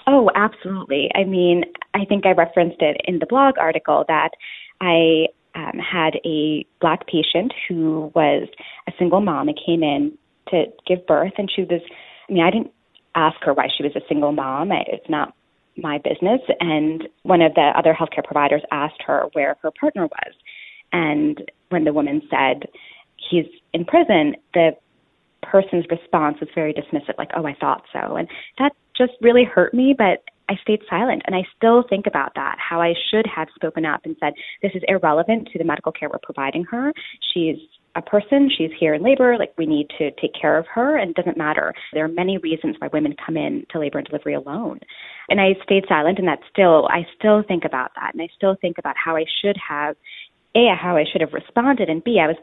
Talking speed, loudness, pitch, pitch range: 205 wpm, -19 LUFS, 175 Hz, 160-210 Hz